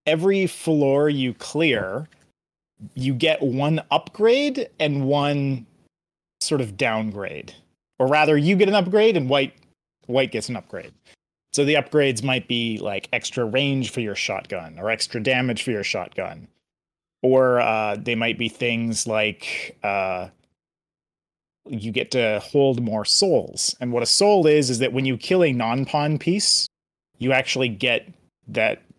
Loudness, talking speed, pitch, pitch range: -21 LUFS, 155 wpm, 130 Hz, 115-150 Hz